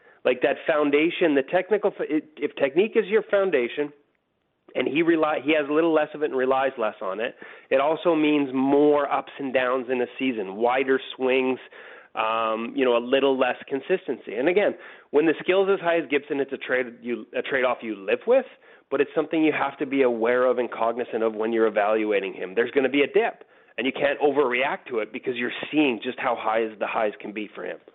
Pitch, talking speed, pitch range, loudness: 140 Hz, 225 wpm, 120-155 Hz, -24 LUFS